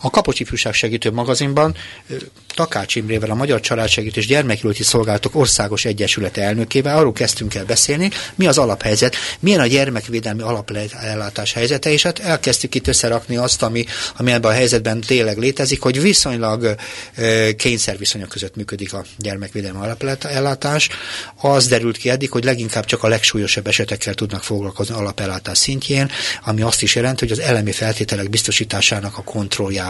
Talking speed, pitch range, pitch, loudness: 145 wpm, 105-130 Hz, 115 Hz, -17 LUFS